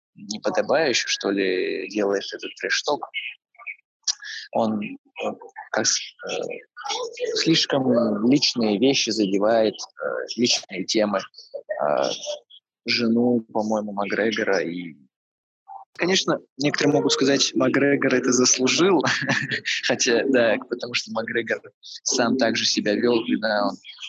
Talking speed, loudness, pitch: 90 wpm, -22 LUFS, 135 Hz